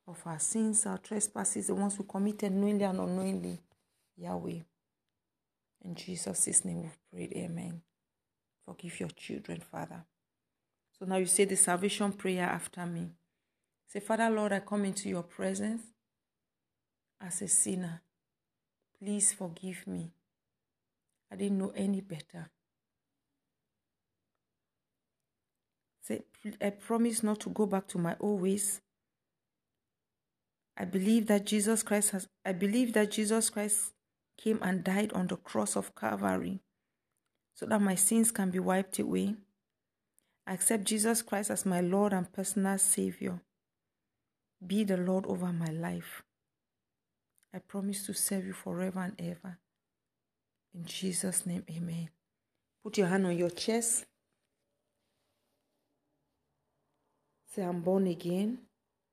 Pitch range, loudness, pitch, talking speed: 175-205 Hz, -32 LUFS, 190 Hz, 130 wpm